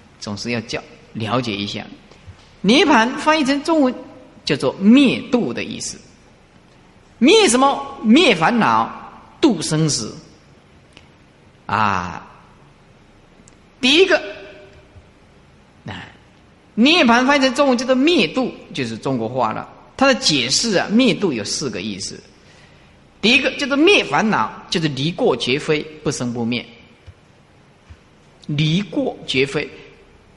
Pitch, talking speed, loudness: 210 Hz, 175 characters per minute, -17 LUFS